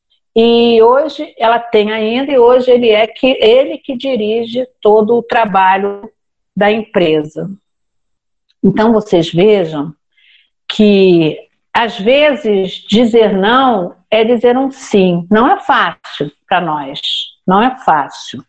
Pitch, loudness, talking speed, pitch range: 220 Hz, -11 LUFS, 125 wpm, 195-250 Hz